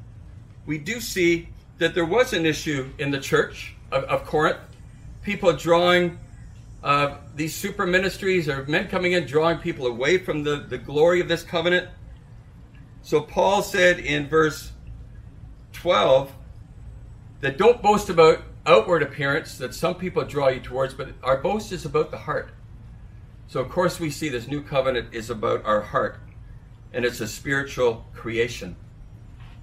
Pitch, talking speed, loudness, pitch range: 140 Hz, 155 wpm, -23 LUFS, 120-170 Hz